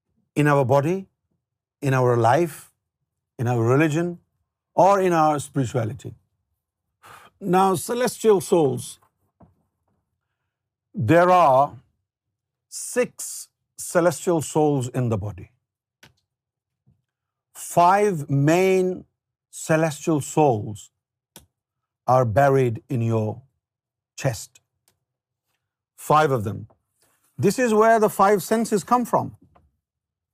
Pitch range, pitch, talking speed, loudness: 110-165 Hz, 130 Hz, 80 wpm, -21 LUFS